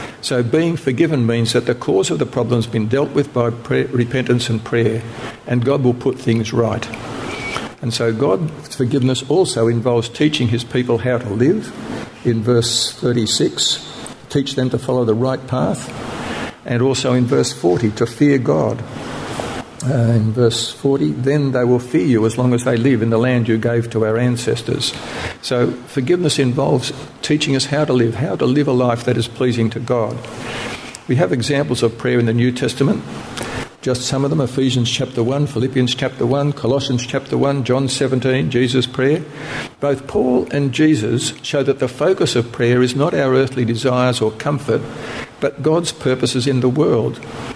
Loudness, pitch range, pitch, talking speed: -17 LUFS, 120-135 Hz, 125 Hz, 180 wpm